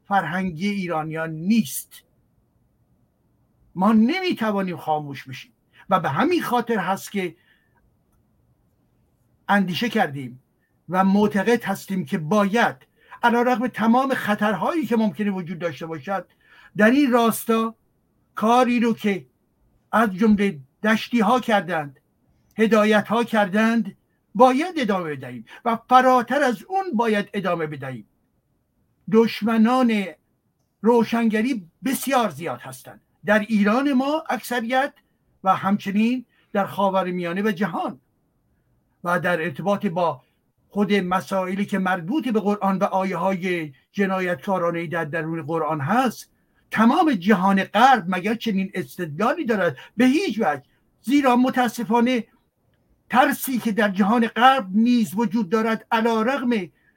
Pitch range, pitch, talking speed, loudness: 180-235 Hz, 210 Hz, 115 wpm, -21 LUFS